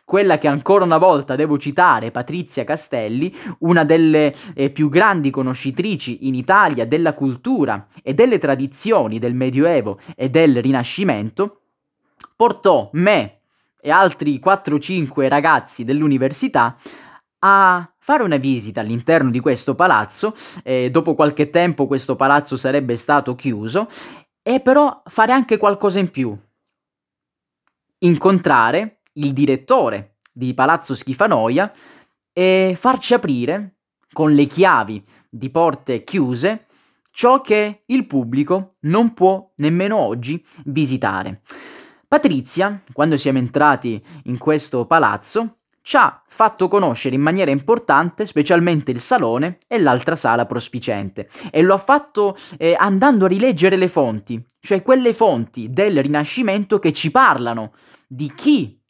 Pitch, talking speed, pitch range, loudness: 155 Hz, 125 wpm, 135-195 Hz, -17 LUFS